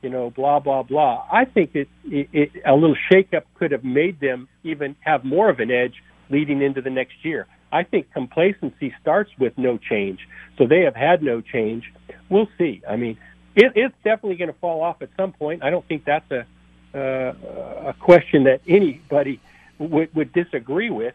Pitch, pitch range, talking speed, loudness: 145 Hz, 130-170 Hz, 200 wpm, -20 LUFS